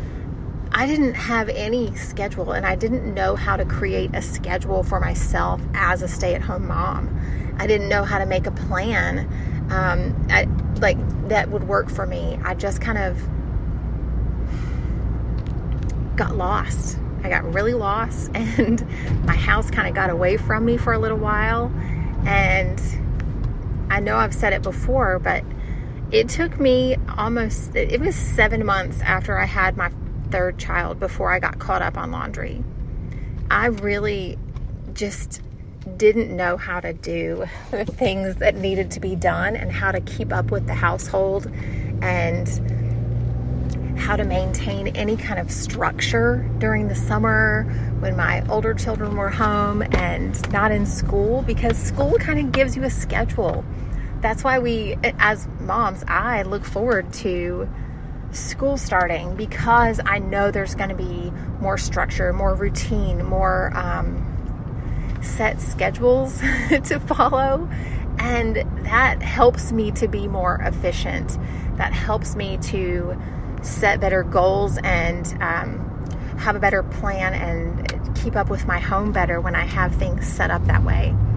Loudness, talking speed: -22 LUFS, 150 wpm